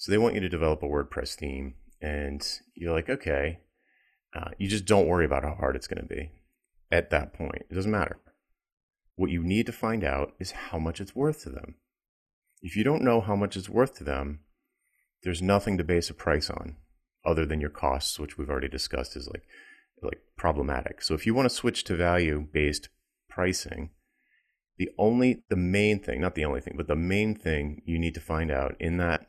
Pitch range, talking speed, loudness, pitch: 75-100 Hz, 210 wpm, -29 LUFS, 85 Hz